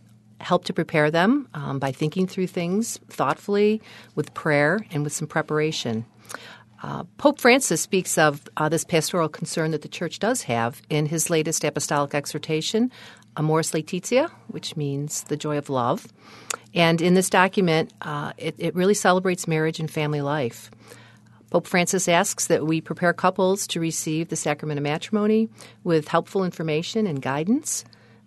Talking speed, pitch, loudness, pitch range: 155 wpm, 160 Hz, -23 LUFS, 150-185 Hz